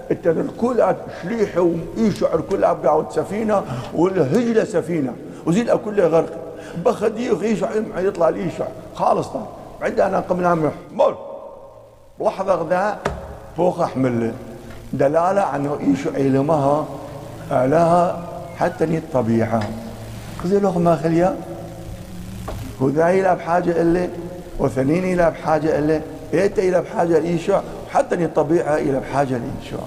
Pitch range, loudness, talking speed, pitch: 140-180 Hz, -20 LUFS, 105 wpm, 165 Hz